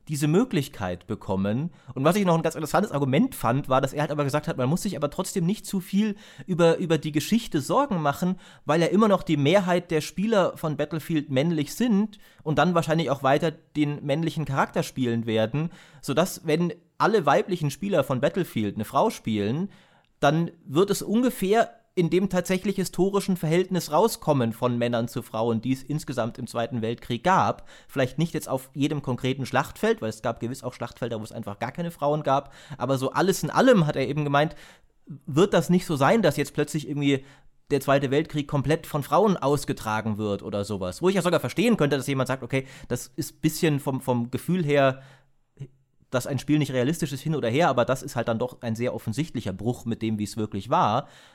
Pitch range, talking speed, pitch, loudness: 130-170 Hz, 205 wpm, 145 Hz, -25 LUFS